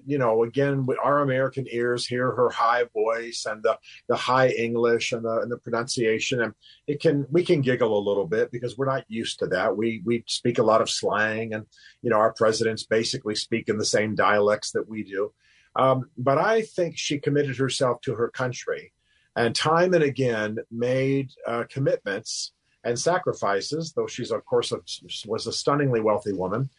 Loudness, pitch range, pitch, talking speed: -25 LUFS, 115-145 Hz, 125 Hz, 190 wpm